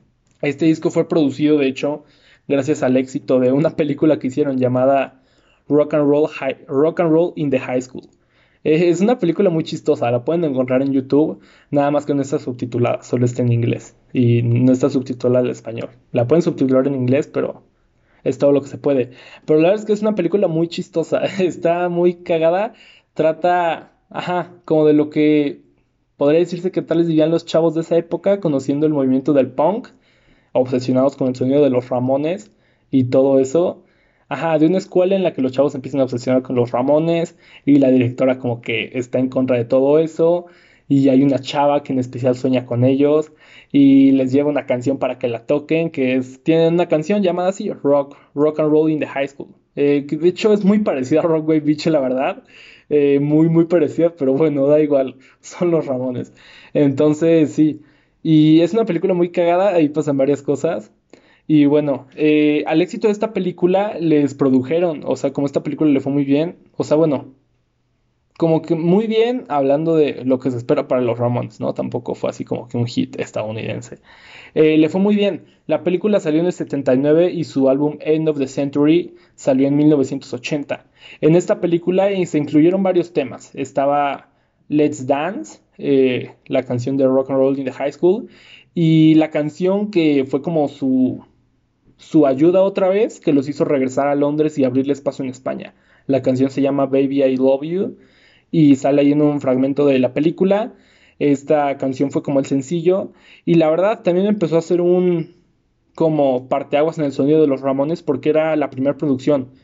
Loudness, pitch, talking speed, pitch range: -17 LUFS, 145 Hz, 195 wpm, 135-165 Hz